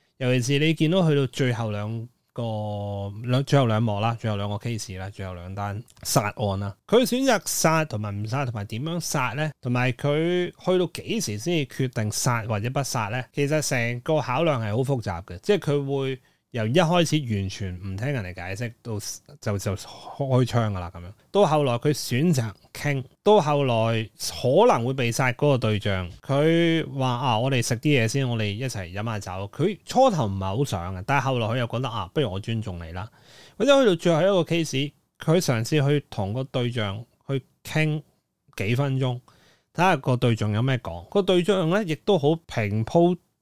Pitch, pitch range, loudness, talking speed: 125 Hz, 110-150 Hz, -24 LUFS, 280 characters per minute